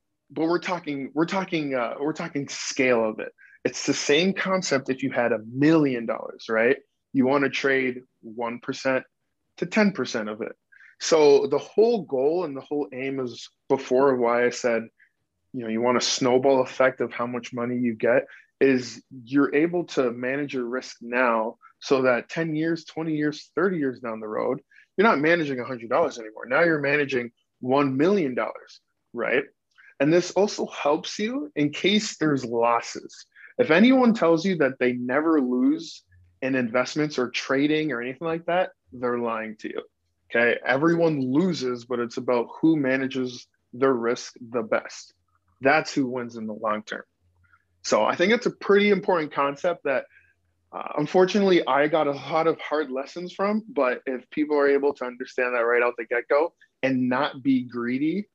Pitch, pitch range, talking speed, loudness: 135 Hz, 125-160 Hz, 180 wpm, -24 LUFS